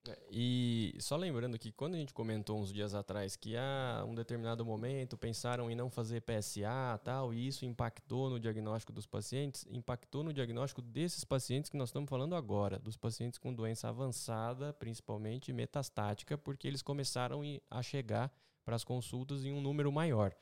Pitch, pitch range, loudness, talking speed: 125 Hz, 115-135 Hz, -40 LUFS, 175 wpm